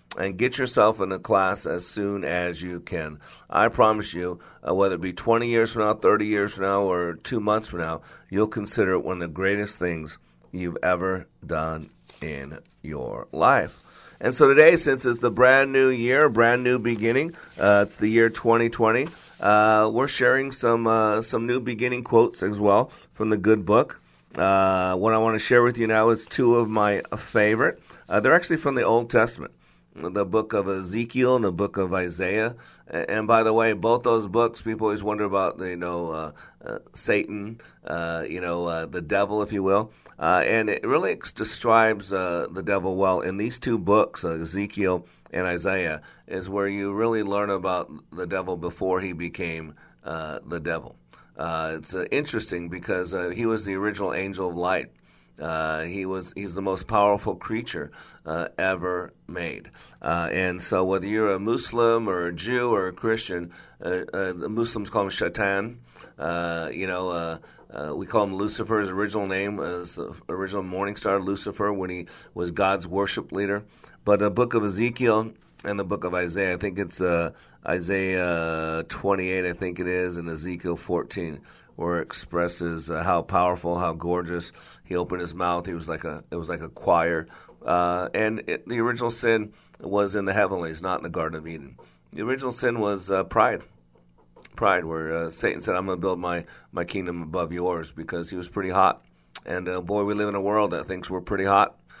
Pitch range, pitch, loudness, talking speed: 90-110 Hz, 95 Hz, -24 LUFS, 195 wpm